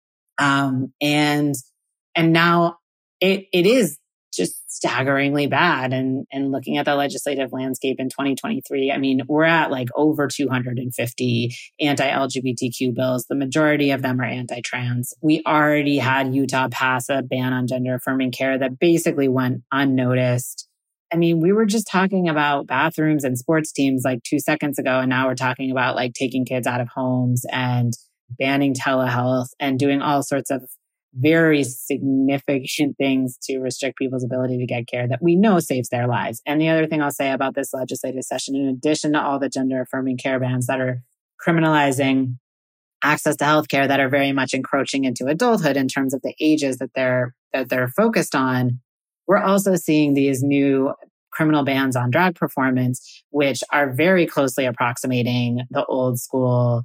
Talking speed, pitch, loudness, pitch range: 170 wpm, 135 Hz, -20 LUFS, 130-145 Hz